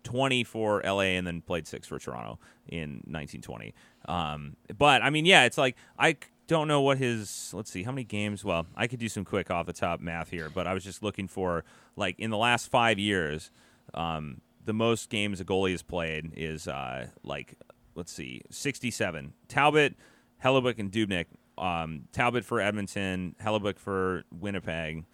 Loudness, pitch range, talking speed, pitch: -29 LUFS, 85-115 Hz, 180 wpm, 100 Hz